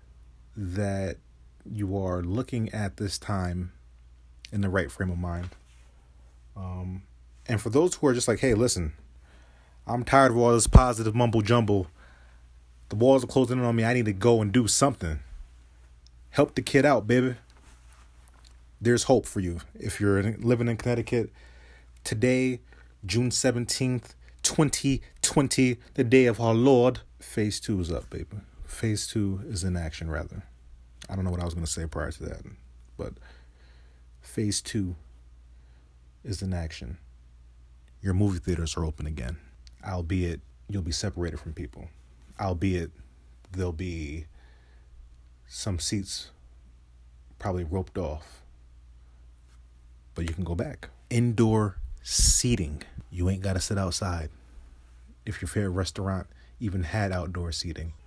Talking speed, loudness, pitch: 145 wpm, -27 LUFS, 90 Hz